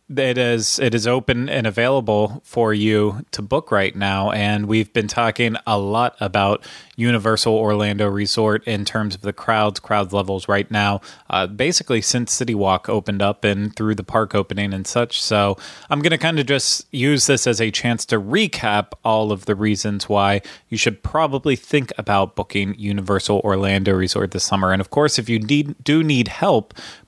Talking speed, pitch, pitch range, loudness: 190 wpm, 110 Hz, 100-120 Hz, -19 LUFS